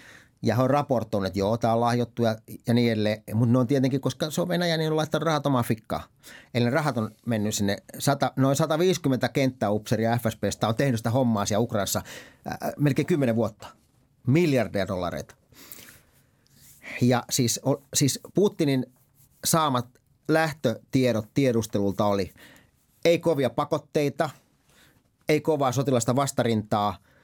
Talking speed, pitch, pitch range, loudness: 145 wpm, 130 Hz, 115-140 Hz, -25 LUFS